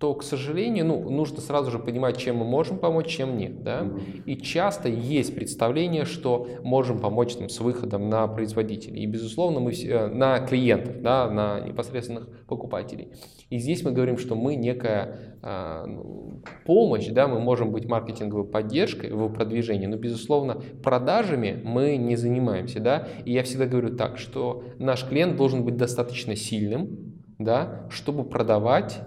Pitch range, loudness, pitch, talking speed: 110-135 Hz, -26 LUFS, 120 Hz, 155 wpm